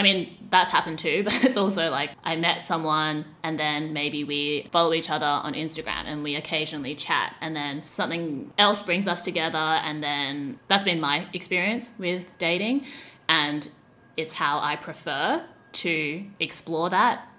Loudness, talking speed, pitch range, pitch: -25 LUFS, 165 wpm, 150-180 Hz, 160 Hz